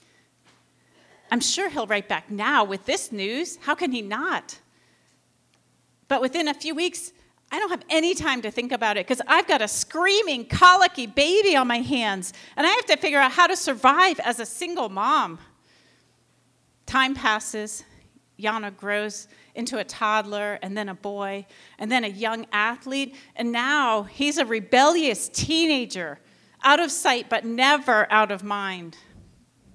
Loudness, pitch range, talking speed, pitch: -22 LUFS, 215-305 Hz, 160 wpm, 250 Hz